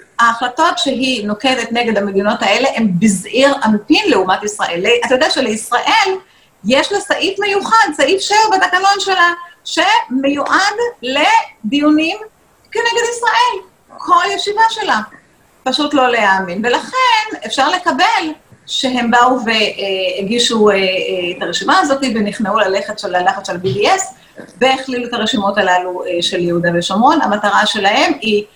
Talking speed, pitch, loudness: 115 wpm, 260 Hz, -13 LUFS